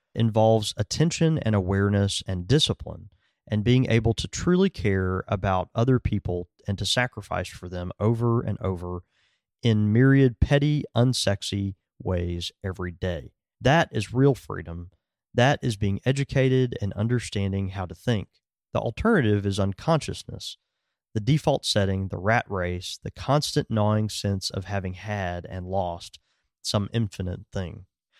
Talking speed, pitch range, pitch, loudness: 140 wpm, 95-120 Hz, 105 Hz, -25 LUFS